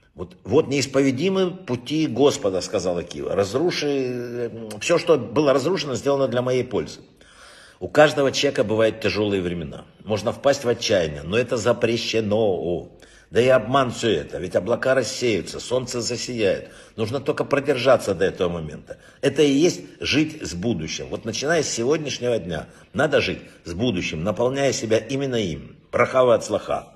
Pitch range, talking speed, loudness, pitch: 110-140 Hz, 150 wpm, -22 LUFS, 125 Hz